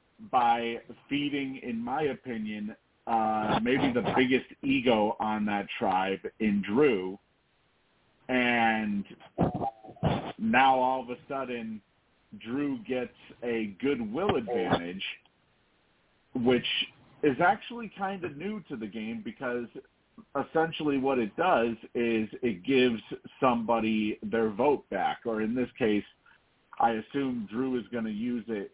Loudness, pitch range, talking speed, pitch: -29 LUFS, 110-140 Hz, 125 wpm, 120 Hz